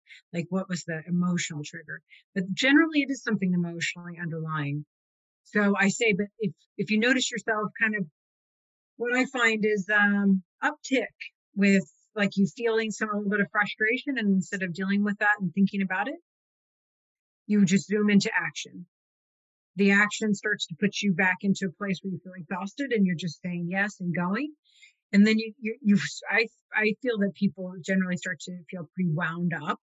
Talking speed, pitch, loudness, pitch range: 185 wpm, 200 Hz, -26 LUFS, 180-215 Hz